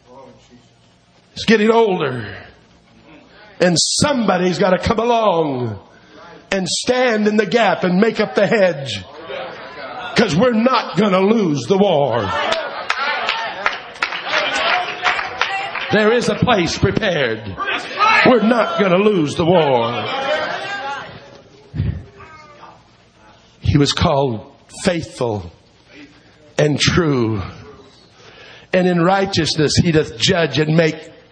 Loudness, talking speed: -16 LUFS, 100 wpm